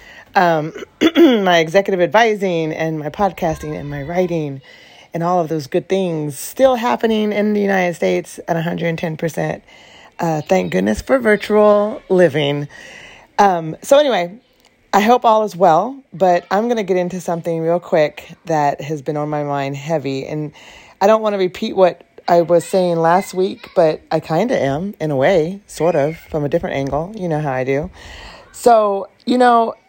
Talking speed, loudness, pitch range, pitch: 175 wpm, -17 LUFS, 155-205 Hz, 175 Hz